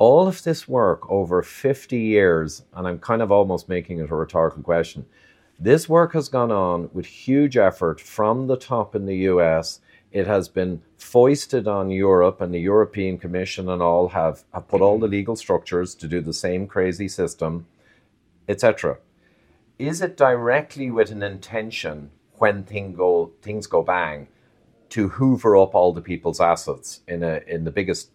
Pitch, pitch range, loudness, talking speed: 100 Hz, 90-115 Hz, -21 LUFS, 175 wpm